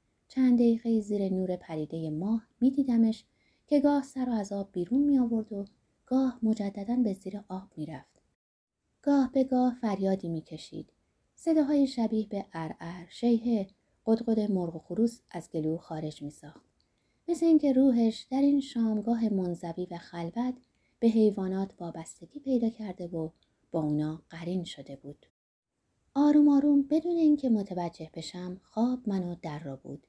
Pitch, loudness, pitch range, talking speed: 210 Hz, -29 LUFS, 175-250 Hz, 155 wpm